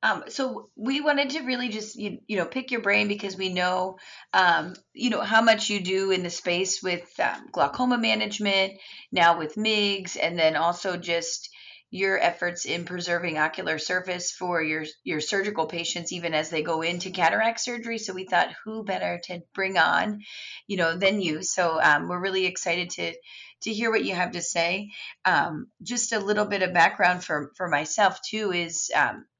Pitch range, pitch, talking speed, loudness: 175-215 Hz, 185 Hz, 190 wpm, -25 LUFS